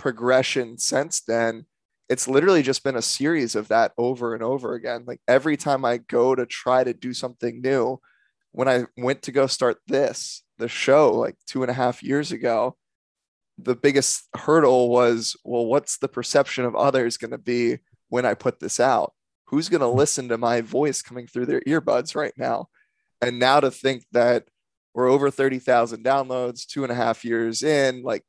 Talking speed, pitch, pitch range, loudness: 190 wpm, 125 Hz, 120-135 Hz, -22 LUFS